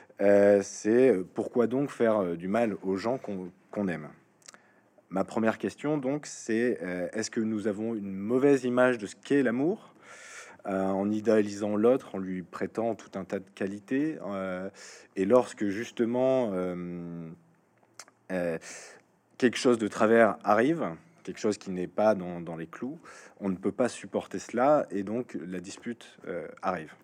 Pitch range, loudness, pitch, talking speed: 95-115 Hz, -29 LUFS, 100 Hz, 160 wpm